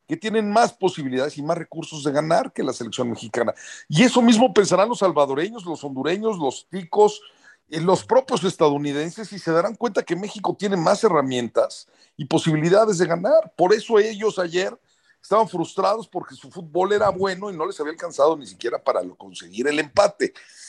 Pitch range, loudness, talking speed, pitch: 155-215 Hz, -21 LUFS, 175 wpm, 185 Hz